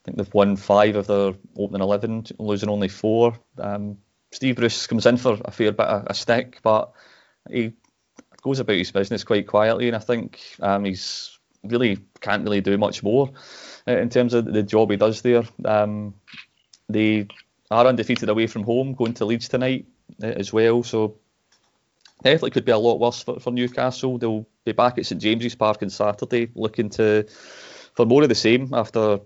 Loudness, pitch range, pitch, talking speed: -21 LUFS, 105-120 Hz, 110 Hz, 185 wpm